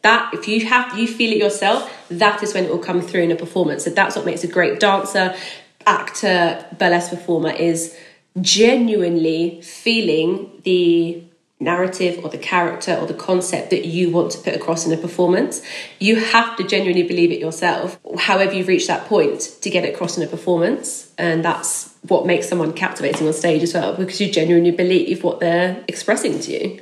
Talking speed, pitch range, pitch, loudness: 190 wpm, 170-195 Hz, 180 Hz, -18 LUFS